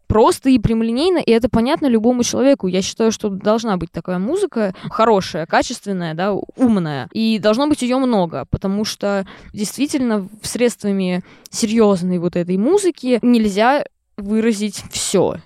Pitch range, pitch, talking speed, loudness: 190-245 Hz, 215 Hz, 135 wpm, -17 LUFS